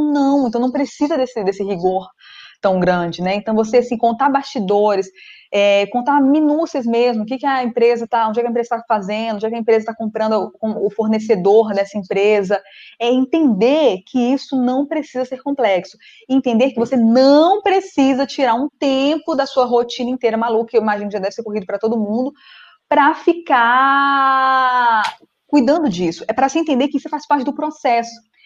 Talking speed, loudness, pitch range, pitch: 190 wpm, -16 LUFS, 220-280 Hz, 245 Hz